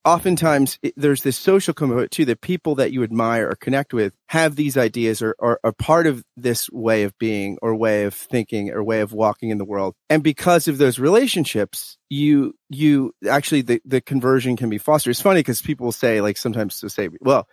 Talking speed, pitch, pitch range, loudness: 210 wpm, 125 Hz, 110-150 Hz, -20 LUFS